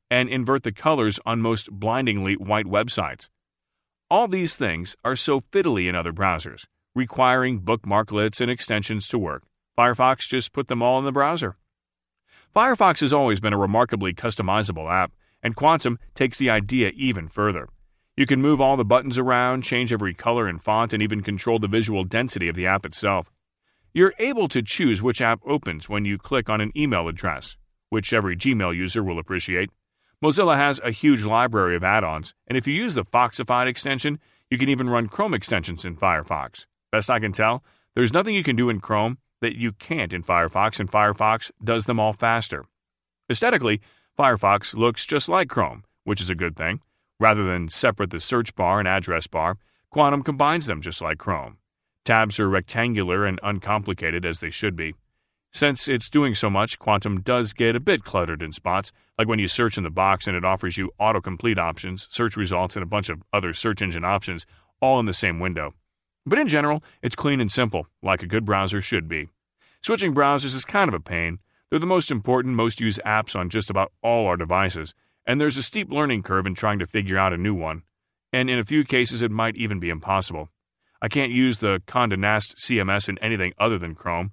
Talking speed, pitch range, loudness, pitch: 200 wpm, 95-125 Hz, -23 LUFS, 110 Hz